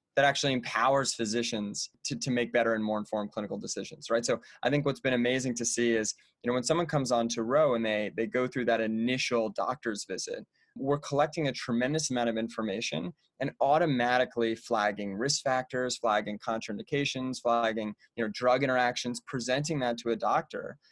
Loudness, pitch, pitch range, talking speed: -30 LUFS, 120 Hz, 115-130 Hz, 185 wpm